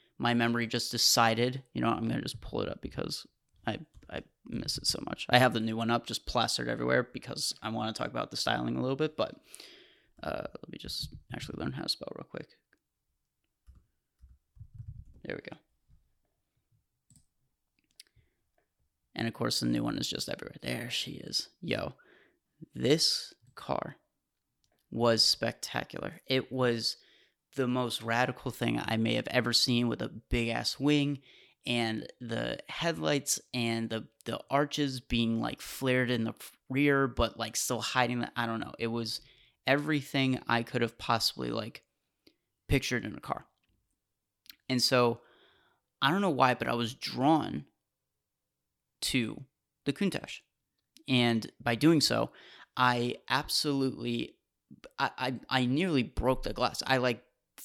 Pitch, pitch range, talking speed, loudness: 120 Hz, 115-130 Hz, 155 wpm, -31 LUFS